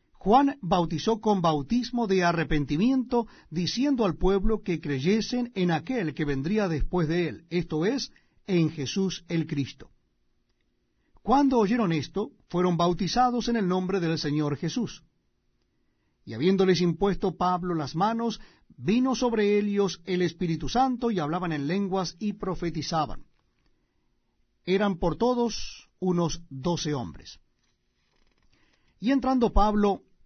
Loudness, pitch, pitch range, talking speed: -27 LUFS, 185 Hz, 165-220 Hz, 125 wpm